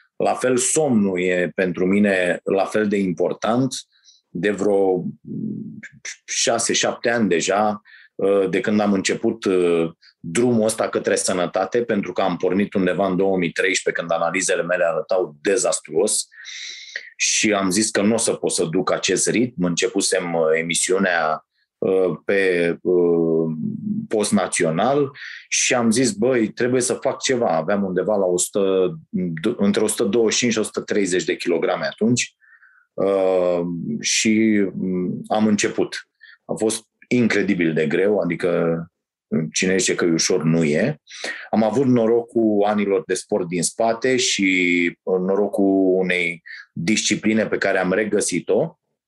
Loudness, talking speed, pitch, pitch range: -20 LUFS, 130 wpm, 95 Hz, 90-110 Hz